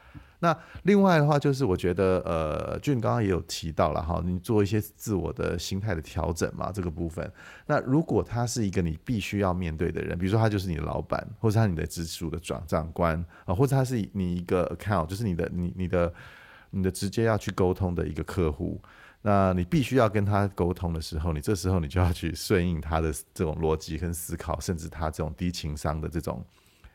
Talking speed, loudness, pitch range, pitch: 335 characters per minute, -28 LUFS, 85-105 Hz, 90 Hz